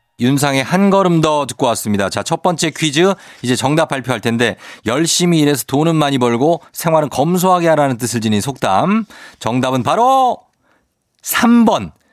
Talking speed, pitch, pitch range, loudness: 305 characters per minute, 150 Hz, 125-180 Hz, -15 LUFS